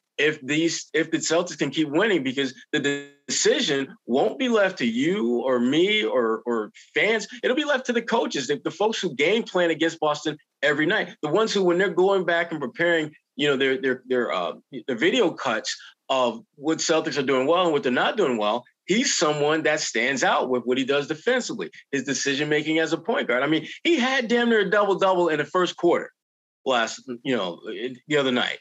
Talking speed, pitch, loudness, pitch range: 215 wpm, 160 Hz, -23 LUFS, 140-190 Hz